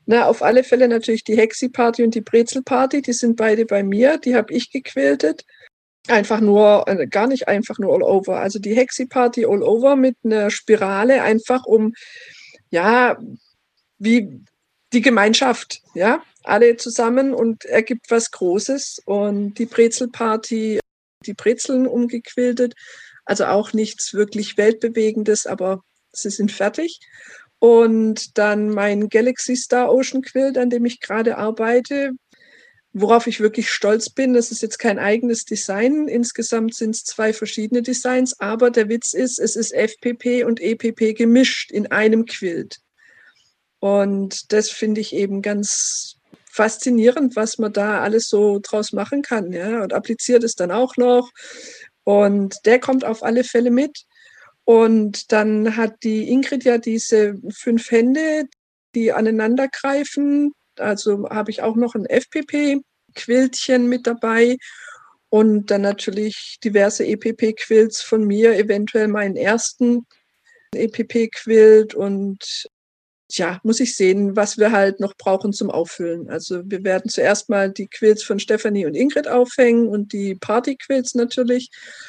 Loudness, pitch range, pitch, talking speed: -18 LUFS, 210-250 Hz, 225 Hz, 145 wpm